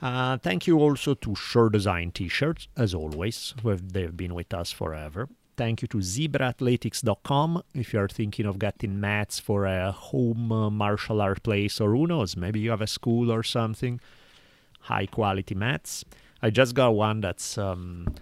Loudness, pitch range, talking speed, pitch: -27 LUFS, 100-125 Hz, 180 wpm, 110 Hz